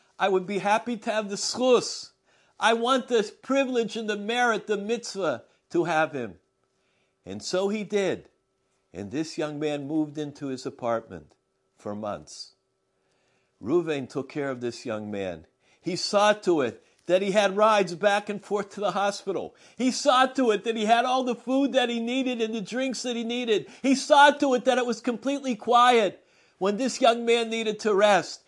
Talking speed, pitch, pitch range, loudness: 190 wpm, 210 Hz, 160-240 Hz, -25 LUFS